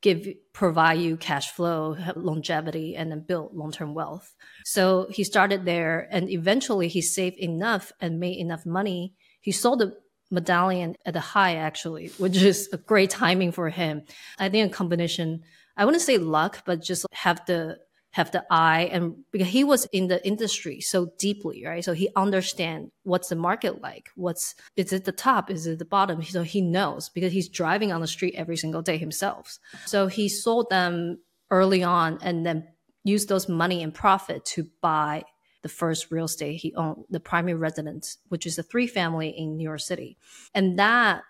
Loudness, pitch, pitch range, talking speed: -25 LUFS, 180 Hz, 165-195 Hz, 185 wpm